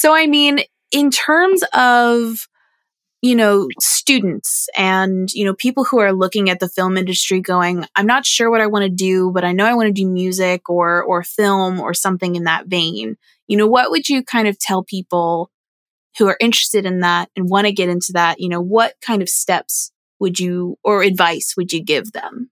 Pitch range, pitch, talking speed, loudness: 180-230 Hz, 190 Hz, 210 wpm, -15 LUFS